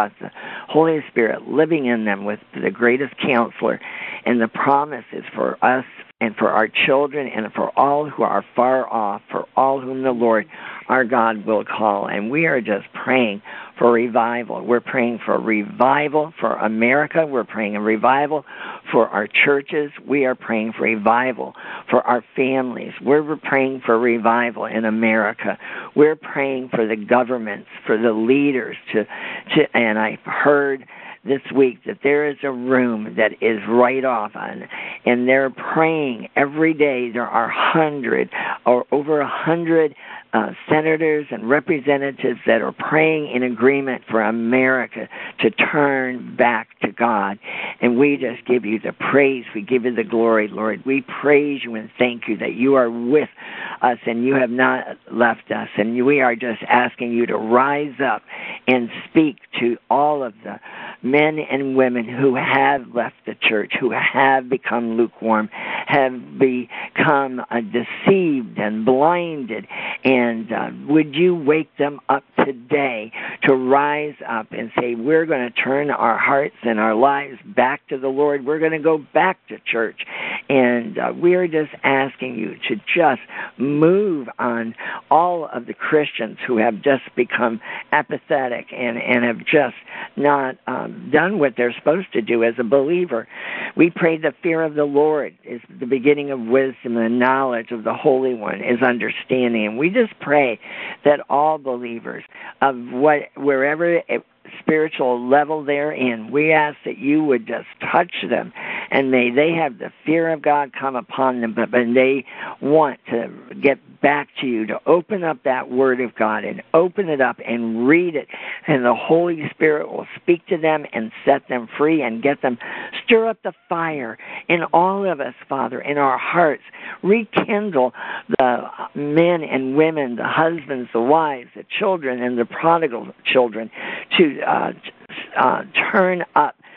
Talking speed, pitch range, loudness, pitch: 165 wpm, 120-150 Hz, -19 LUFS, 135 Hz